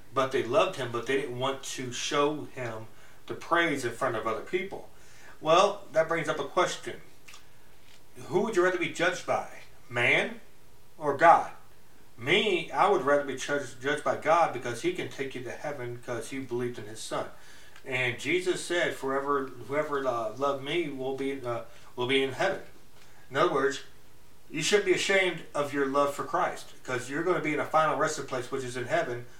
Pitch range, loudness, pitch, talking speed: 125-155 Hz, -29 LUFS, 140 Hz, 195 wpm